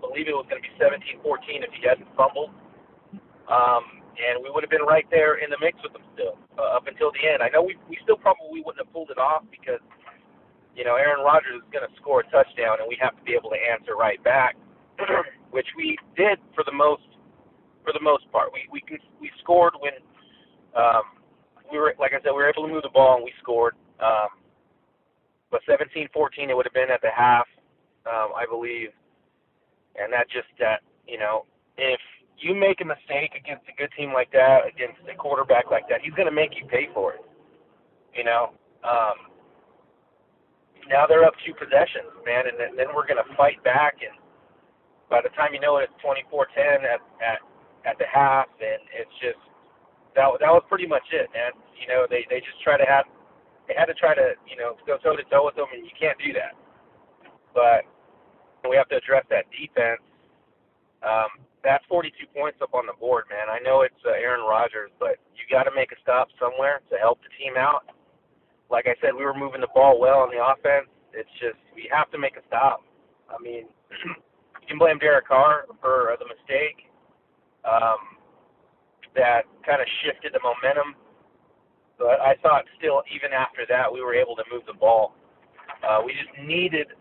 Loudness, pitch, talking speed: -23 LUFS, 155 Hz, 205 wpm